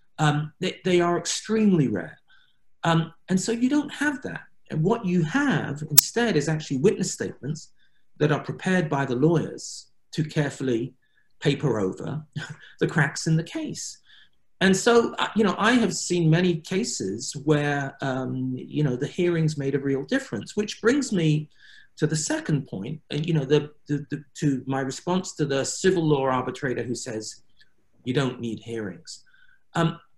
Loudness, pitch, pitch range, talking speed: -25 LUFS, 155 Hz, 140-185 Hz, 170 wpm